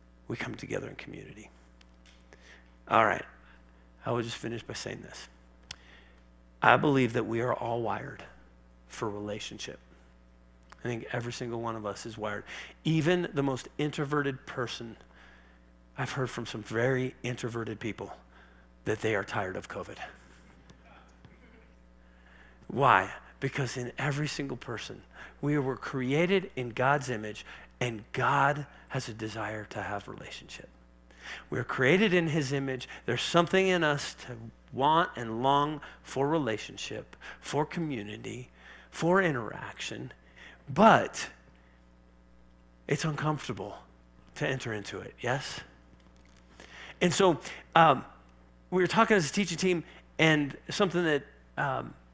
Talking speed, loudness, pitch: 130 wpm, -30 LUFS, 115 Hz